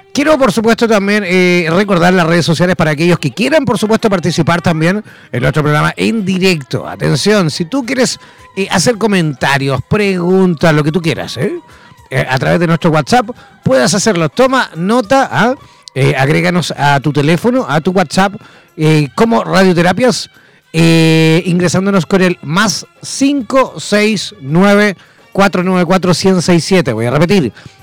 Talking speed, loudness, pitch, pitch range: 140 wpm, -11 LUFS, 185 Hz, 165-210 Hz